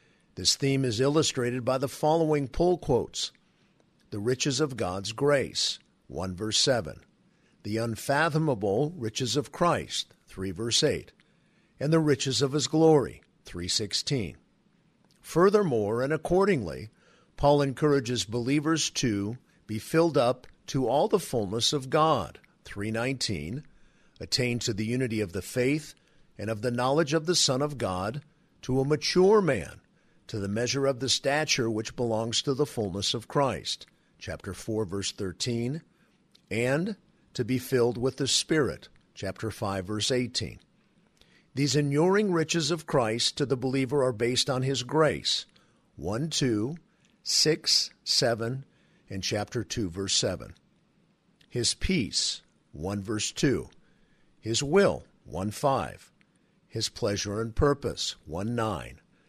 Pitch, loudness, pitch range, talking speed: 130 Hz, -27 LUFS, 110-155 Hz, 140 wpm